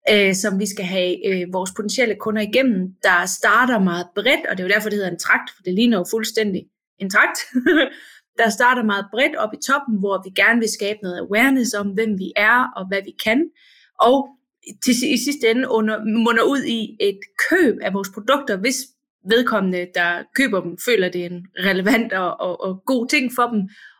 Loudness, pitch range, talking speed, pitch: -19 LUFS, 195-250 Hz, 200 wpm, 220 Hz